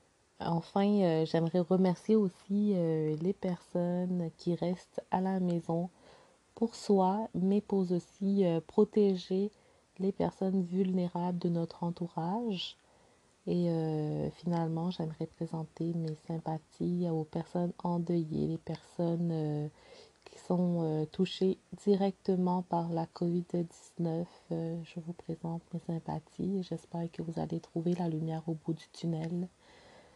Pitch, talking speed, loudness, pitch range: 175 Hz, 125 wpm, -34 LUFS, 165-185 Hz